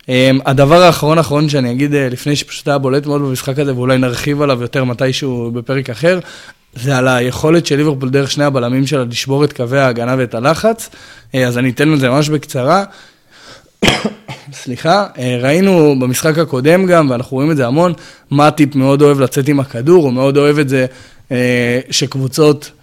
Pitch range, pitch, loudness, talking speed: 130-150 Hz, 140 Hz, -13 LUFS, 180 wpm